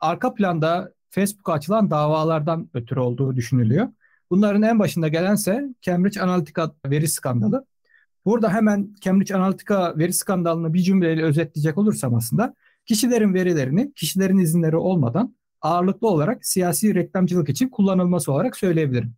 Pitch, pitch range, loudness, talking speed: 180 Hz, 160-205 Hz, -21 LUFS, 125 wpm